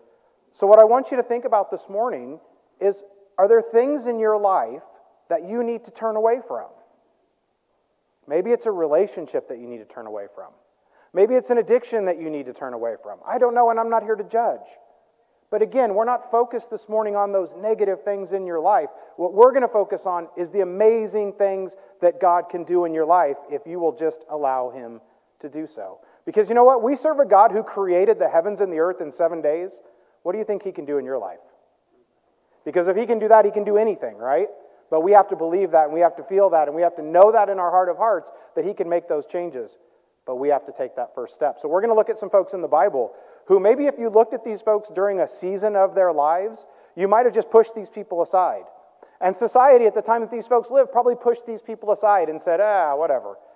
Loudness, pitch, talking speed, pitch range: -20 LUFS, 210 Hz, 250 wpm, 175-235 Hz